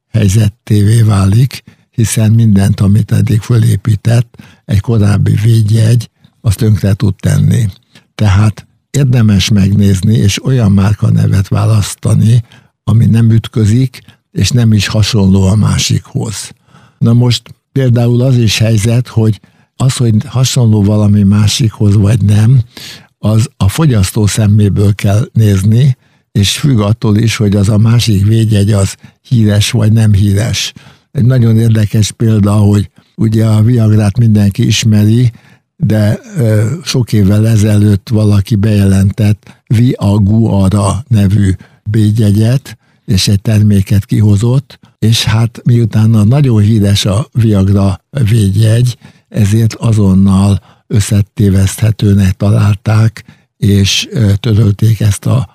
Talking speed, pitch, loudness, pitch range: 110 wpm, 110 Hz, -10 LUFS, 105-120 Hz